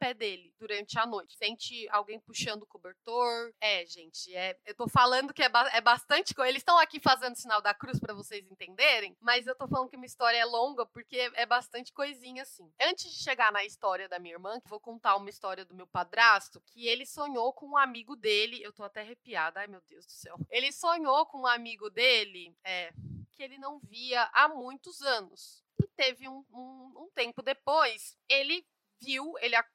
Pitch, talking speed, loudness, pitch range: 235 Hz, 210 wpm, -29 LUFS, 210-265 Hz